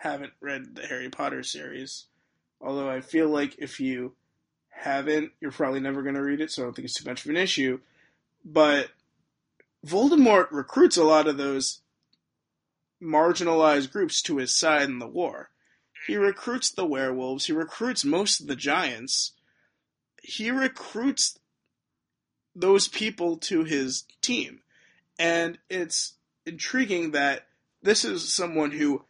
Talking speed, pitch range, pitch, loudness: 145 wpm, 140-195 Hz, 155 Hz, -25 LUFS